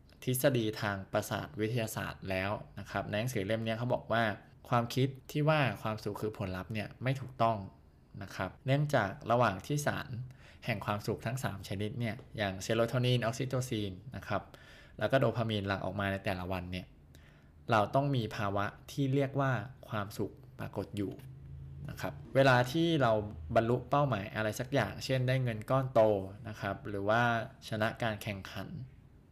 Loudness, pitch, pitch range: -33 LUFS, 110 Hz, 100-130 Hz